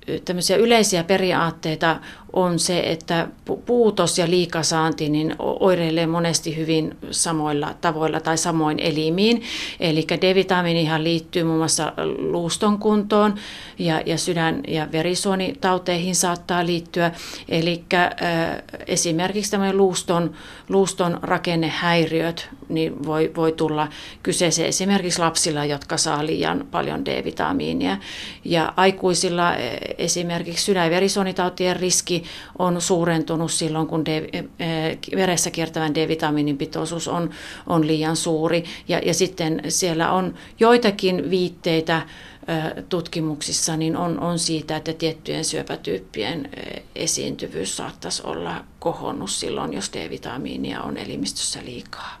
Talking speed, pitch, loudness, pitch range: 105 wpm, 170 Hz, -22 LUFS, 160-180 Hz